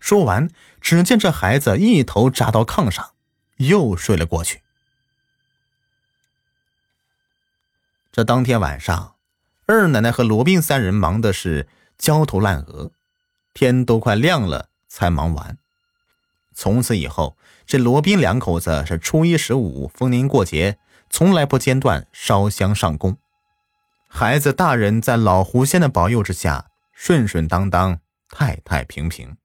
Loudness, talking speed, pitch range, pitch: -18 LUFS, 195 characters per minute, 95-155 Hz, 125 Hz